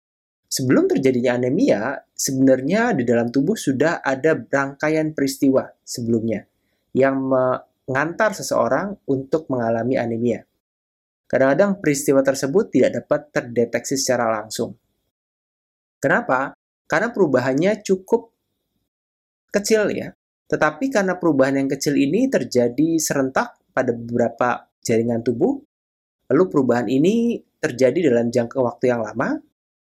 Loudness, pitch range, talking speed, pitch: -20 LUFS, 120-160 Hz, 105 wpm, 135 Hz